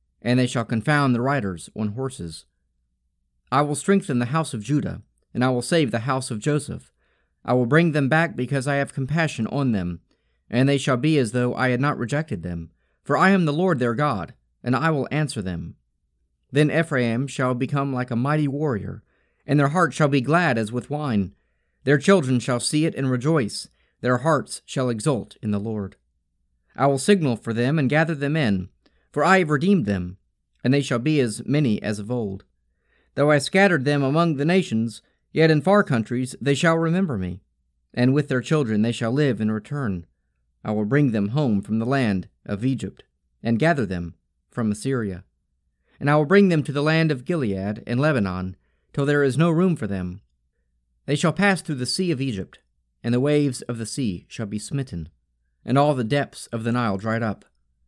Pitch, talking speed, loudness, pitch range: 125 Hz, 200 wpm, -22 LUFS, 100-145 Hz